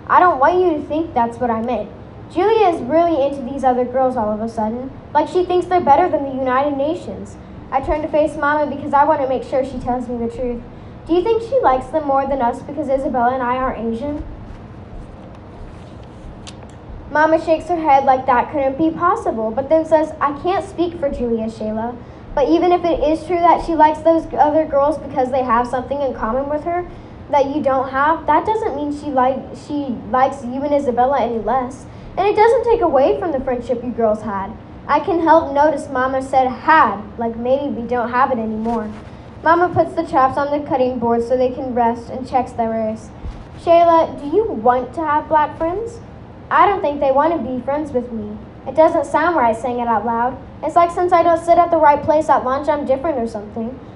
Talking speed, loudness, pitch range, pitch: 220 wpm, -17 LUFS, 250-320 Hz, 280 Hz